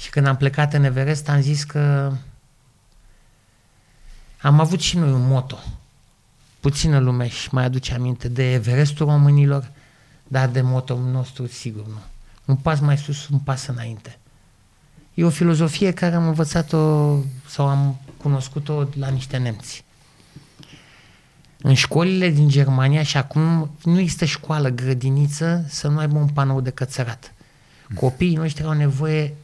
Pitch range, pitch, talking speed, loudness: 130-150 Hz, 140 Hz, 145 wpm, -20 LUFS